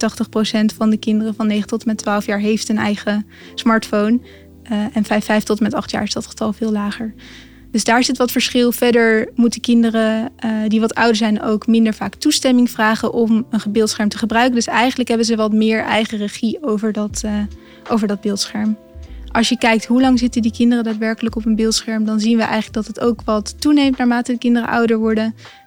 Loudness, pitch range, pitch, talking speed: -17 LUFS, 215-235 Hz, 225 Hz, 215 wpm